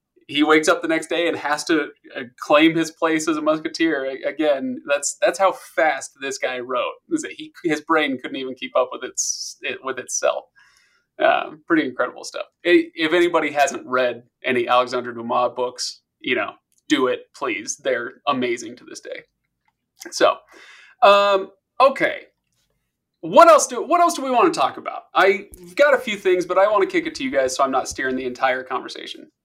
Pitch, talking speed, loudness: 195 Hz, 185 wpm, -20 LUFS